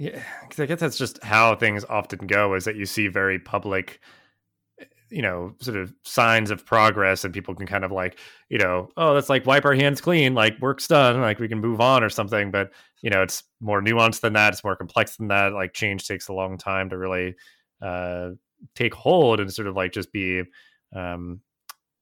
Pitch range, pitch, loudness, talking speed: 95-115 Hz, 100 Hz, -22 LUFS, 215 wpm